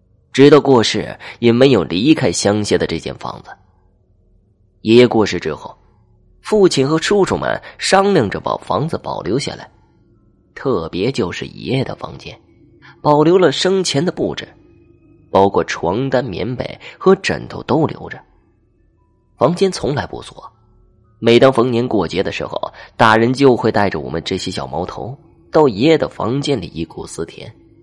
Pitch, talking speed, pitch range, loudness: 115 Hz, 230 characters per minute, 95-140 Hz, -15 LUFS